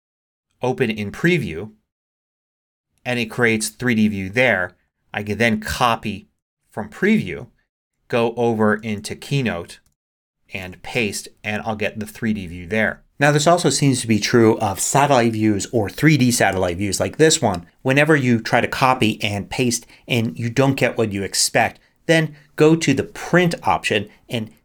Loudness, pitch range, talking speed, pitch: -19 LUFS, 105-135 Hz, 160 wpm, 115 Hz